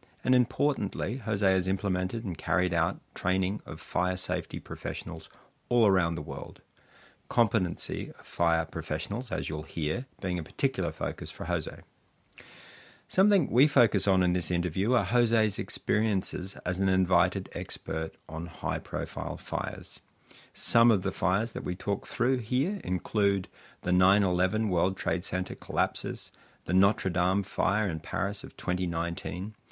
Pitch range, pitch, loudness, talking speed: 85-110 Hz, 95 Hz, -29 LUFS, 145 wpm